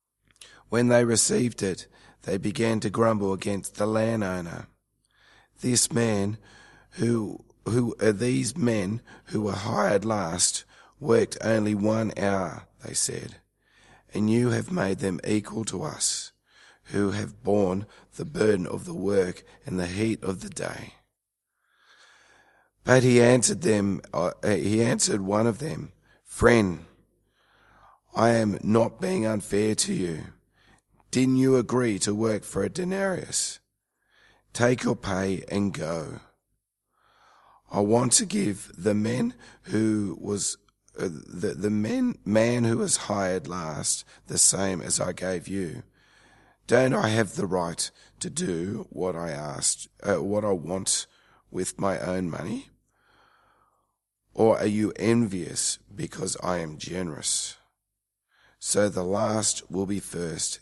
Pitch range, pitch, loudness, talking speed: 100-115 Hz, 105 Hz, -26 LUFS, 135 wpm